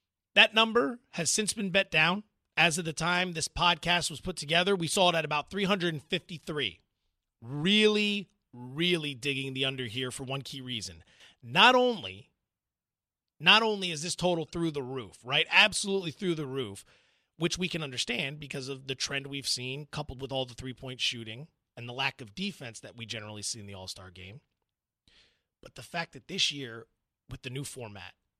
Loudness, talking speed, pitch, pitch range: -28 LUFS, 185 wpm, 145 Hz, 125-175 Hz